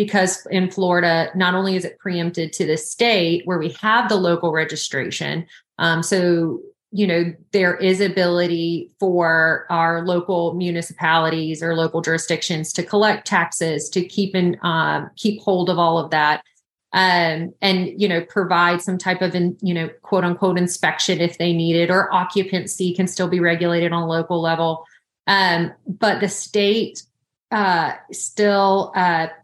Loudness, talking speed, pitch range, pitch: -19 LUFS, 160 wpm, 165-190 Hz, 175 Hz